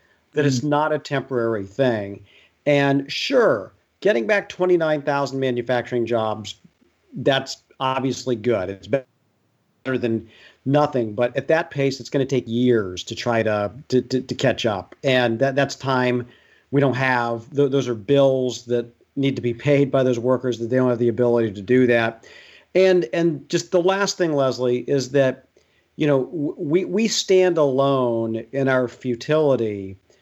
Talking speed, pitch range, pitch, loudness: 165 wpm, 120-140 Hz, 130 Hz, -21 LUFS